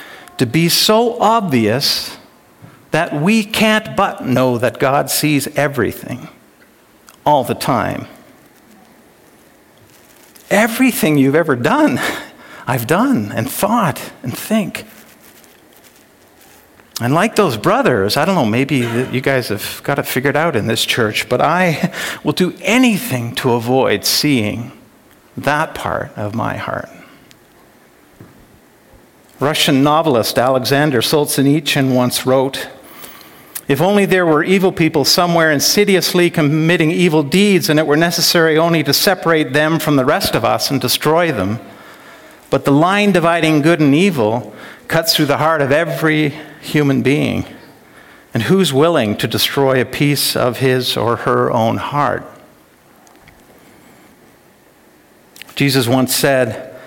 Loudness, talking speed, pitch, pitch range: -14 LUFS, 130 wpm, 150 Hz, 130-175 Hz